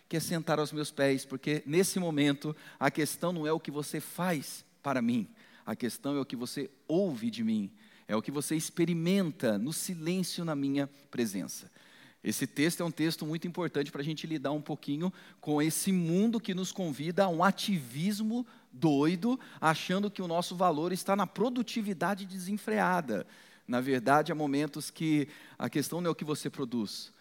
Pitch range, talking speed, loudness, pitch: 145-190 Hz, 185 wpm, -32 LUFS, 165 Hz